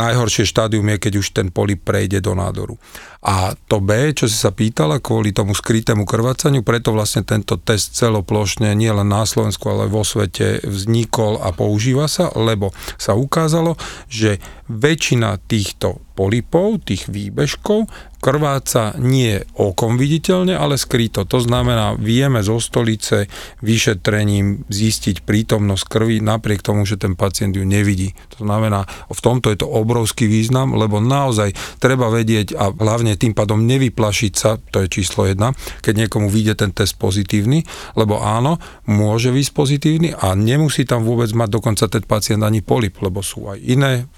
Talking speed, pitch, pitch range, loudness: 160 wpm, 110 Hz, 105-125 Hz, -17 LUFS